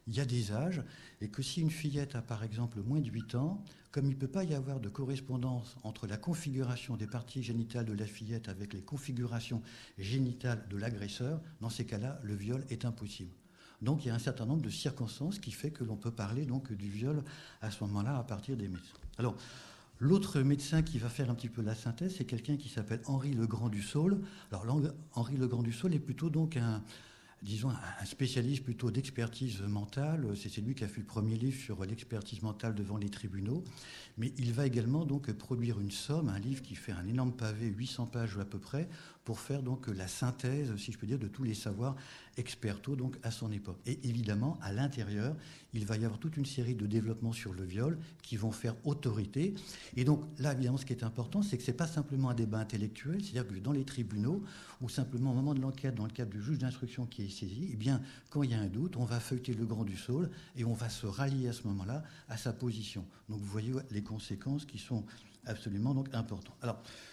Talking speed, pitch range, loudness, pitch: 230 wpm, 110-135 Hz, -37 LUFS, 120 Hz